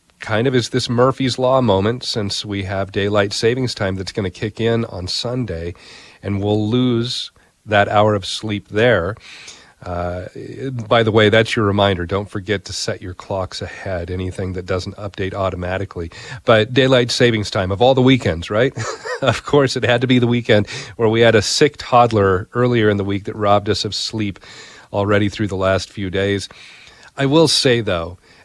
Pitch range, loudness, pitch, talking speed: 95-120 Hz, -17 LUFS, 105 Hz, 190 wpm